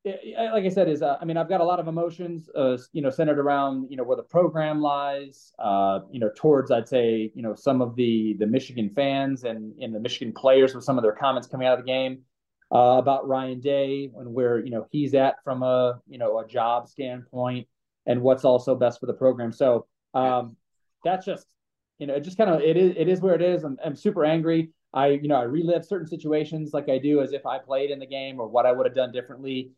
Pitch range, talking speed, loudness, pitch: 125-155 Hz, 245 wpm, -24 LUFS, 135 Hz